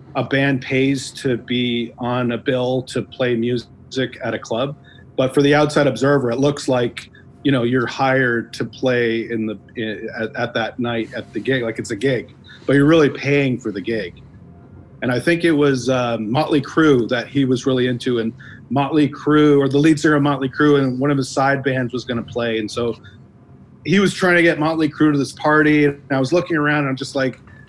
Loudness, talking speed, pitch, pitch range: -18 LUFS, 225 wpm, 130 Hz, 120-145 Hz